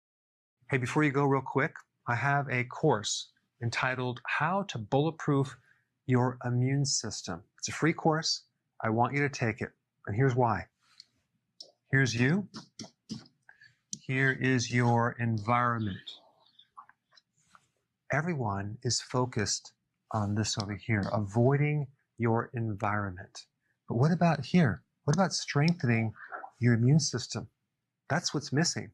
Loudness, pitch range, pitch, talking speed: -30 LUFS, 115-145 Hz, 125 Hz, 120 wpm